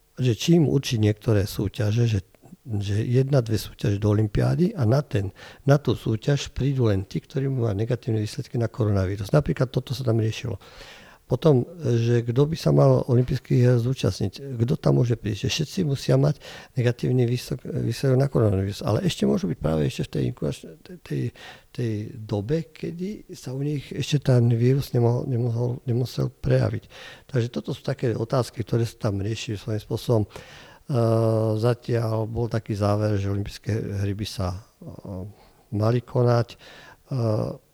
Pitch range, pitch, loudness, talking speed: 110-135 Hz, 120 Hz, -24 LUFS, 155 wpm